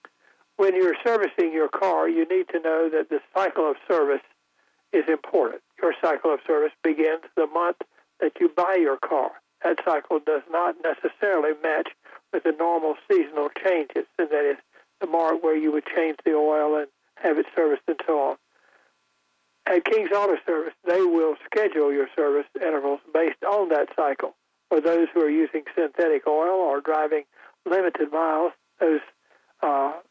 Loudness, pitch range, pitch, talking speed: -24 LUFS, 150-190 Hz, 160 Hz, 165 wpm